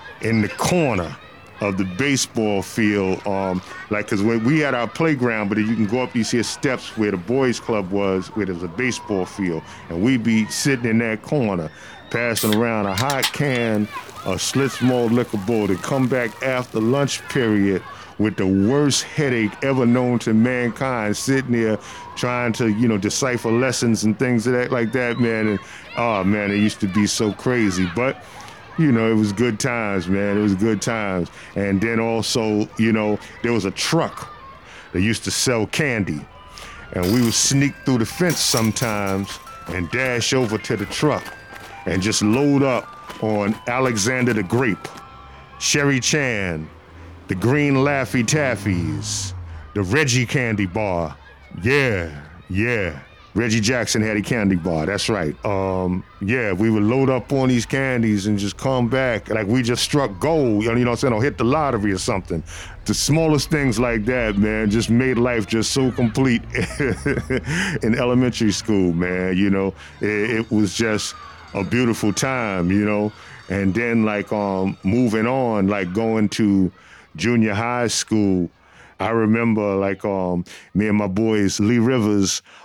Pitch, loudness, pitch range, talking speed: 110 Hz, -20 LUFS, 100-125 Hz, 170 wpm